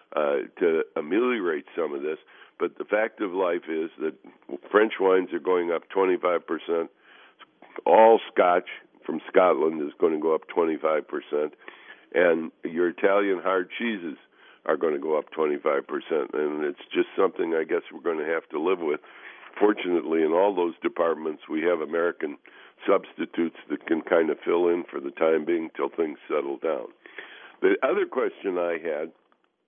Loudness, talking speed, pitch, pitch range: -25 LUFS, 170 wpm, 390 Hz, 350-435 Hz